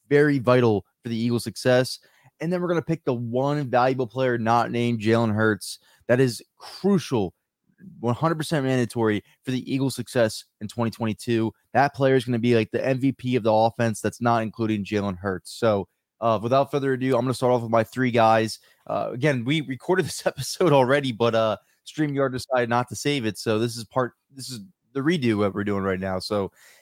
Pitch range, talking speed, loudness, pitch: 110-135 Hz, 205 wpm, -24 LUFS, 120 Hz